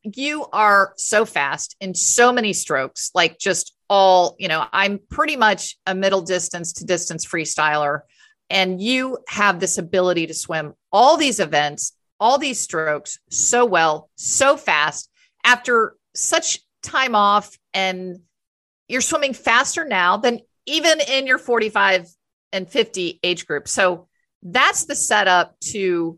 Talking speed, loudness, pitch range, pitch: 140 wpm, -18 LUFS, 175-245 Hz, 195 Hz